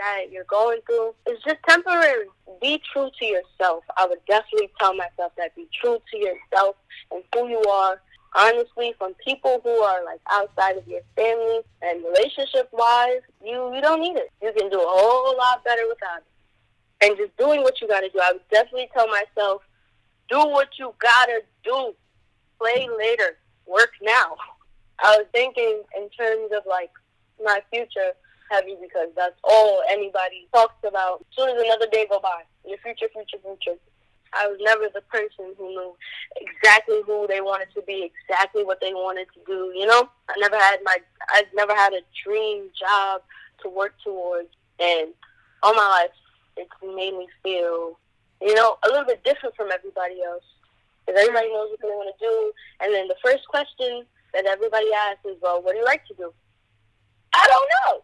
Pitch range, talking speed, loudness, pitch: 190-245 Hz, 180 wpm, -21 LUFS, 210 Hz